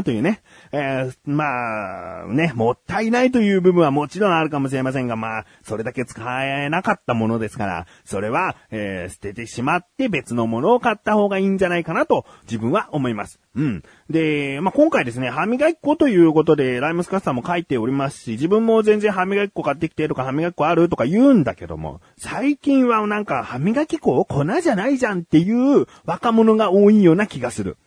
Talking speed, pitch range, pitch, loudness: 420 characters per minute, 125-210 Hz, 160 Hz, -19 LUFS